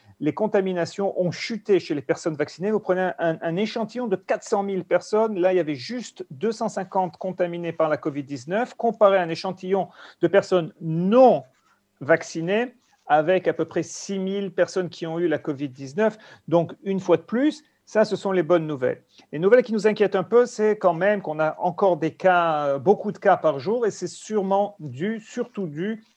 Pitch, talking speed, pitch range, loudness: 185 Hz, 195 wpm, 165-210 Hz, -23 LUFS